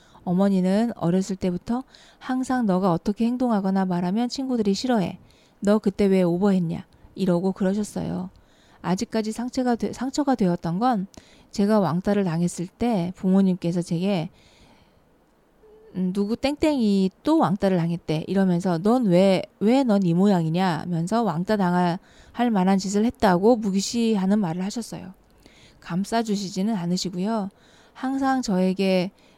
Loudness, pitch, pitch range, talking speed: -23 LUFS, 195 Hz, 180-230 Hz, 295 characters per minute